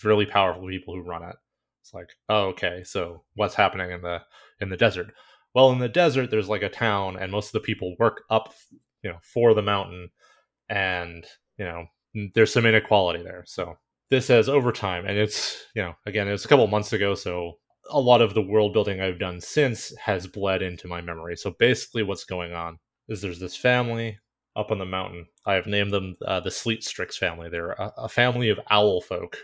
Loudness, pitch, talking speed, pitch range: -24 LUFS, 100 Hz, 215 wpm, 90-110 Hz